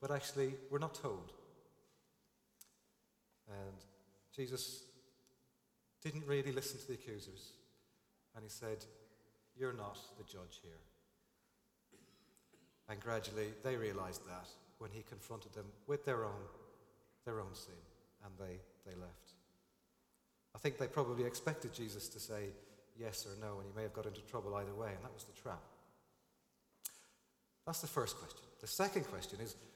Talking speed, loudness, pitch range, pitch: 145 wpm, -45 LUFS, 100-125 Hz, 110 Hz